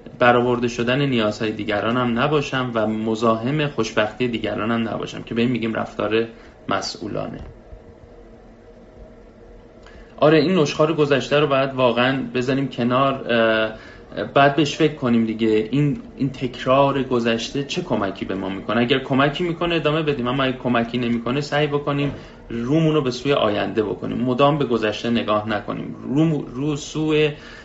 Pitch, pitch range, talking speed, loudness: 125 Hz, 115-140 Hz, 145 wpm, -20 LUFS